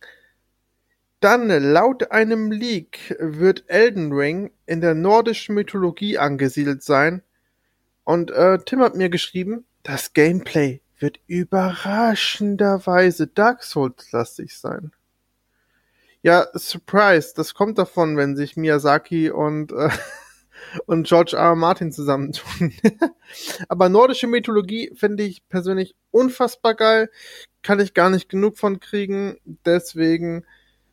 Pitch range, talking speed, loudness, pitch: 160-210 Hz, 115 wpm, -19 LUFS, 185 Hz